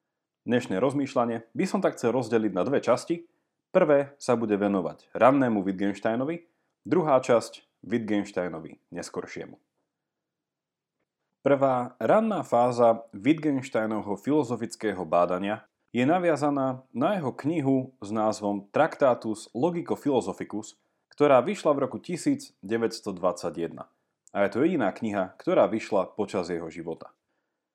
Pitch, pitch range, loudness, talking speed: 120 Hz, 105-150 Hz, -26 LUFS, 110 wpm